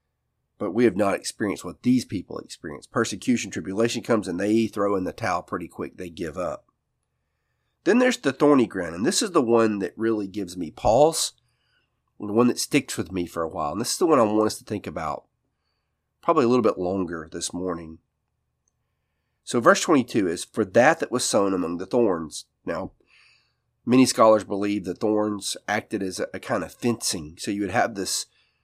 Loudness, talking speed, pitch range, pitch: -24 LUFS, 195 wpm, 95-115 Hz, 105 Hz